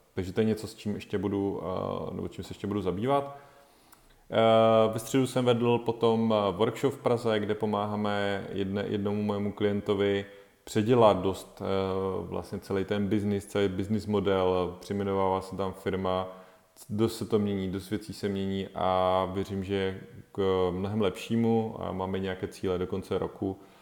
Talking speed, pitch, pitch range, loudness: 155 wpm, 100 Hz, 95-110 Hz, -29 LUFS